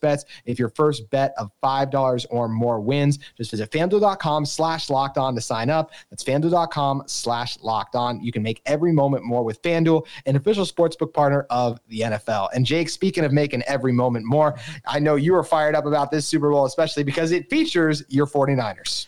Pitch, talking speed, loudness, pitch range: 140 Hz, 200 wpm, -22 LUFS, 120-155 Hz